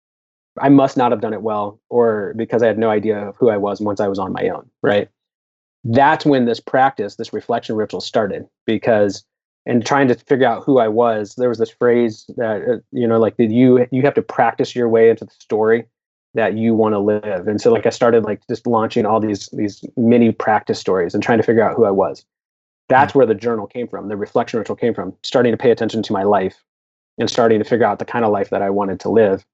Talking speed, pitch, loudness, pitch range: 240 wpm, 110 Hz, -17 LUFS, 105-120 Hz